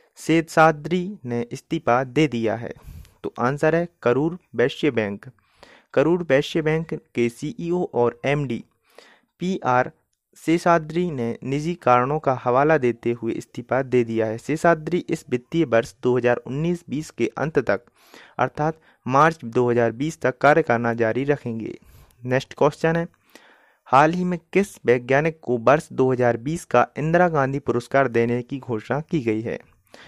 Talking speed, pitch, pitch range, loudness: 140 wpm, 135 Hz, 120-160 Hz, -22 LUFS